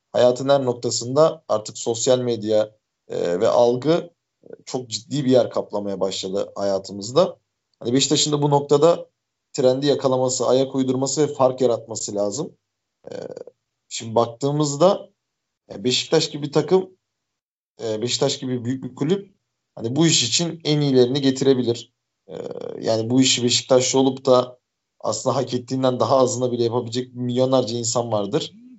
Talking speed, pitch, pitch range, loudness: 130 wpm, 130 Hz, 120-145 Hz, -20 LUFS